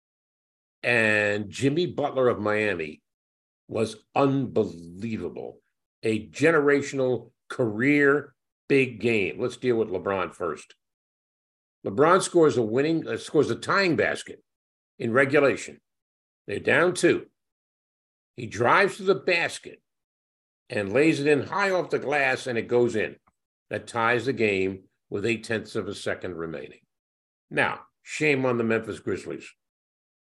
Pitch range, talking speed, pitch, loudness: 105-140 Hz, 130 wpm, 115 Hz, -25 LUFS